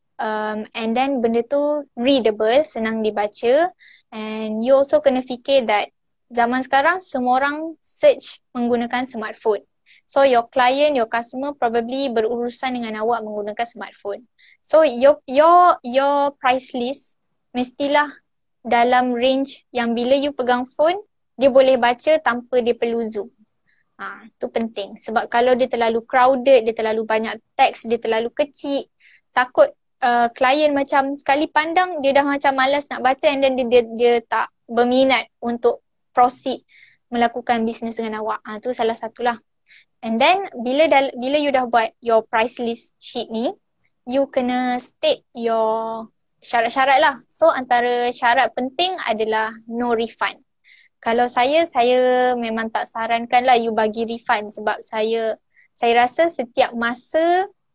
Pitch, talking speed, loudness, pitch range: 245 Hz, 145 wpm, -19 LUFS, 230-275 Hz